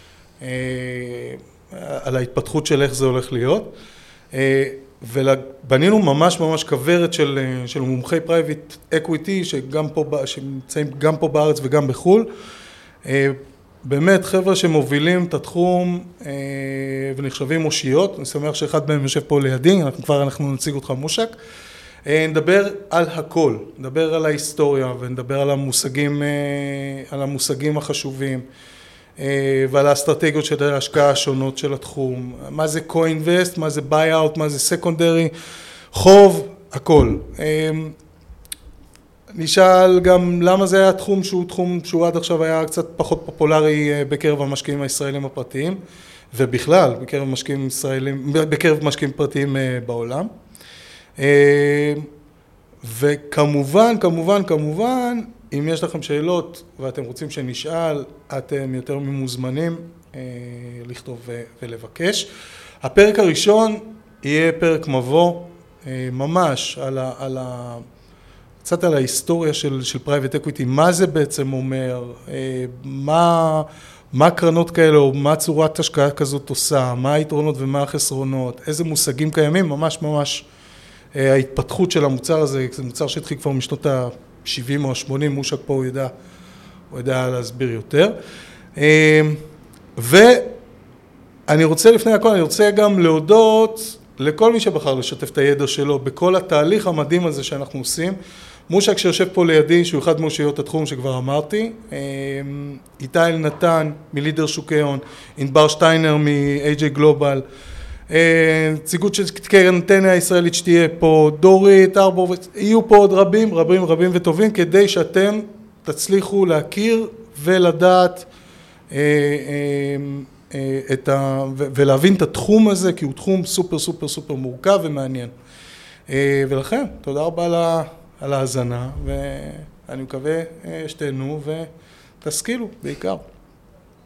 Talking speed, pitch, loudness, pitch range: 120 wpm, 150 Hz, -17 LUFS, 135-170 Hz